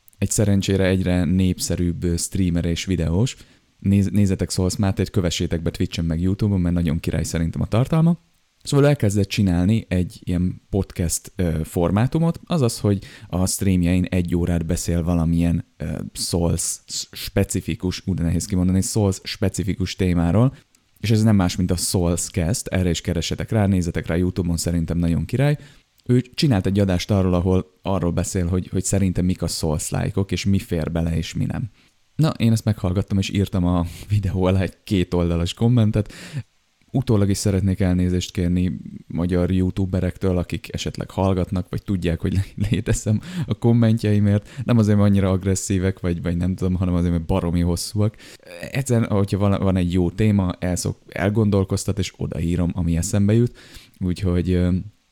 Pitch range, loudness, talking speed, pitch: 90-105 Hz, -21 LUFS, 150 wpm, 95 Hz